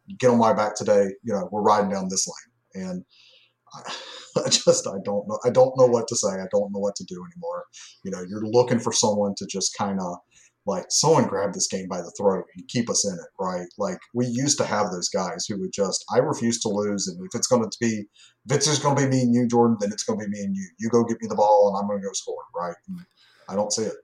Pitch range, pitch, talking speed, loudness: 100-130 Hz, 115 Hz, 275 wpm, -23 LUFS